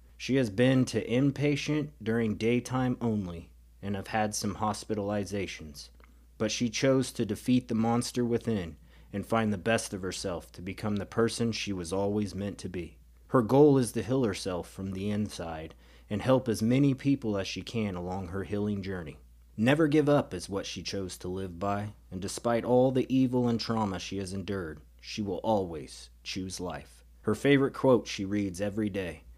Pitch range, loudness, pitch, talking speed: 90-115 Hz, -30 LUFS, 105 Hz, 185 wpm